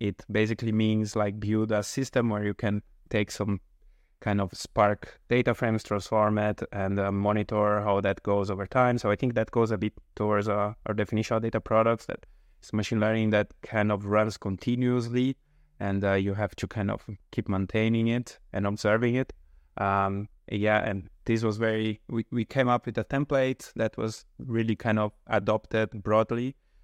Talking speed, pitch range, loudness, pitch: 185 wpm, 105-115 Hz, -28 LUFS, 110 Hz